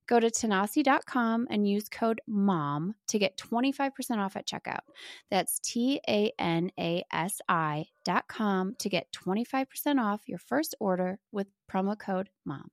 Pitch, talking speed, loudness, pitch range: 205 Hz, 125 wpm, -30 LUFS, 185-235 Hz